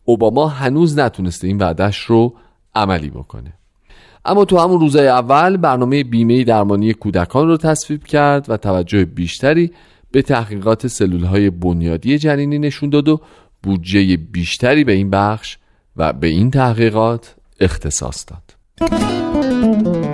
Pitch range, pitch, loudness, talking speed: 95-145 Hz, 115 Hz, -15 LUFS, 130 wpm